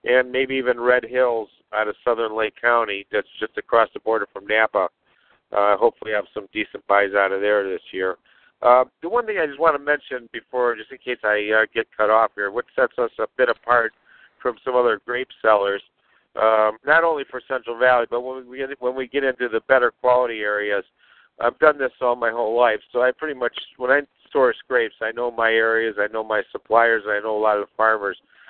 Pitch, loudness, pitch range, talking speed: 120 Hz, -21 LUFS, 110-130 Hz, 225 wpm